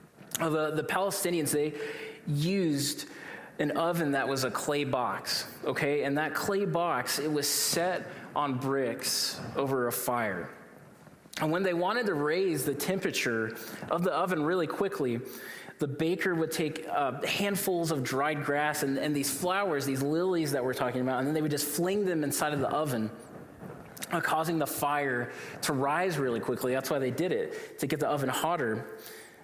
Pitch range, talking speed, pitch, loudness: 140-170 Hz, 175 wpm, 150 Hz, -30 LUFS